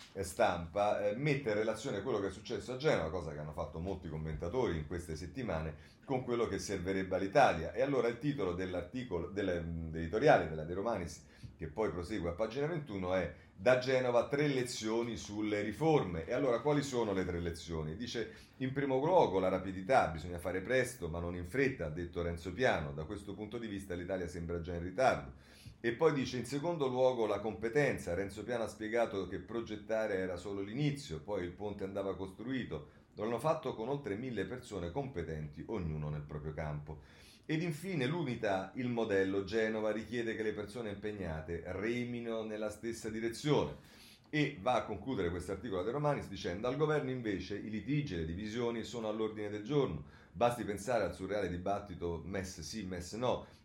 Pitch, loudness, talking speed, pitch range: 105 Hz, -36 LUFS, 180 wpm, 90-120 Hz